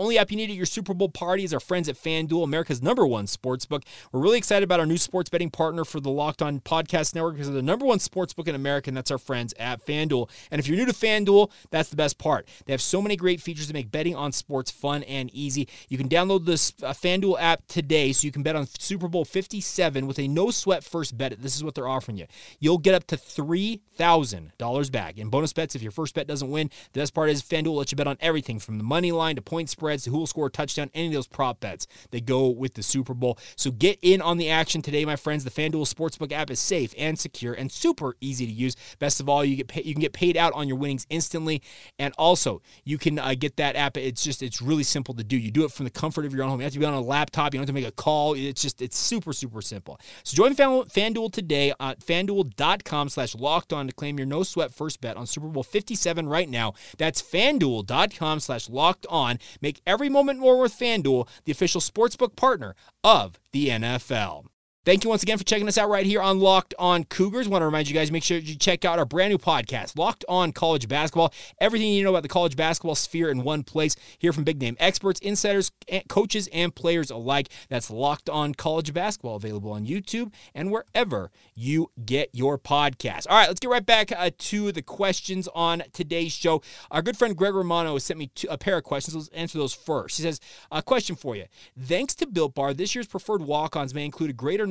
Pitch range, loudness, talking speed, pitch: 135-180 Hz, -25 LUFS, 245 wpm, 155 Hz